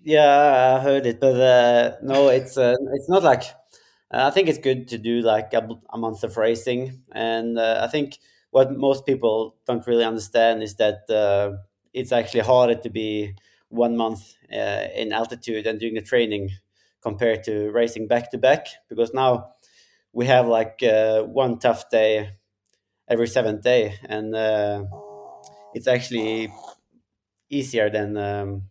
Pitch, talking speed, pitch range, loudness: 115 Hz, 160 wpm, 110-125 Hz, -21 LUFS